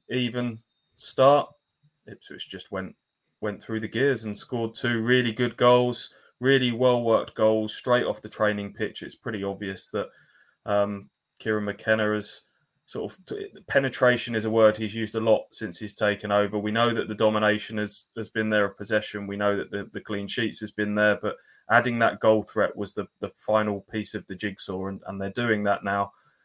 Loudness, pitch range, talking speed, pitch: -26 LUFS, 105-115 Hz, 195 wpm, 110 Hz